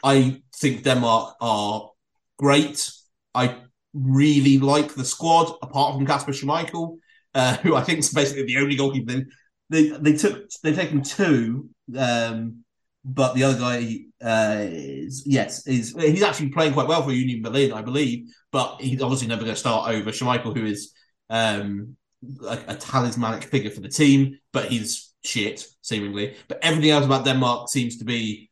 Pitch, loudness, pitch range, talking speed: 130 Hz, -22 LUFS, 115-145 Hz, 165 wpm